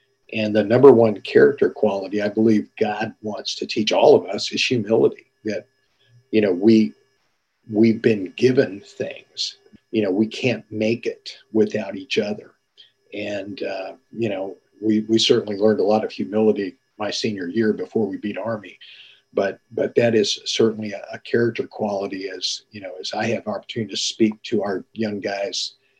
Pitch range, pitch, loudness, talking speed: 105-115 Hz, 110 Hz, -21 LUFS, 175 wpm